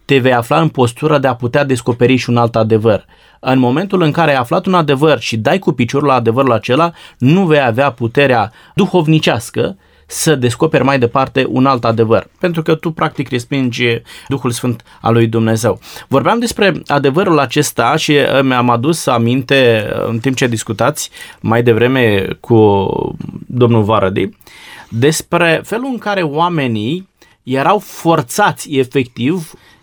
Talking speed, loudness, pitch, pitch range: 150 wpm, -13 LUFS, 135 Hz, 120-160 Hz